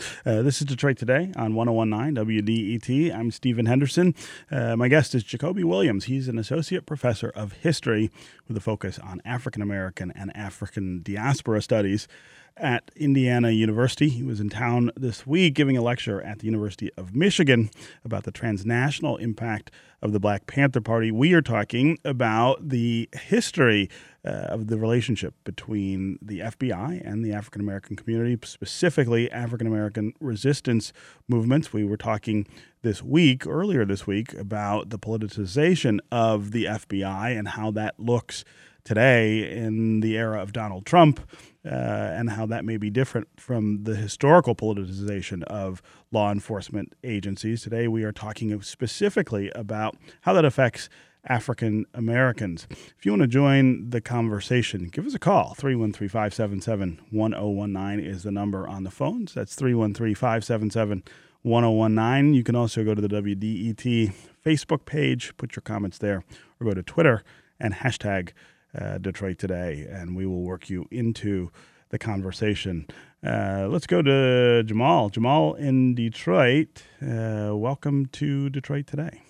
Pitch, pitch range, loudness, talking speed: 115 Hz, 105-130 Hz, -25 LUFS, 150 wpm